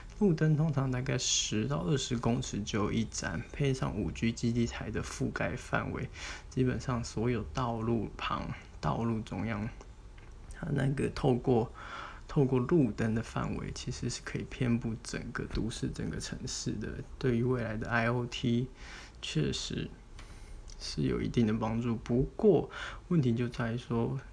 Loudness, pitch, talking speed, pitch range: -33 LUFS, 120 Hz, 230 characters per minute, 115-130 Hz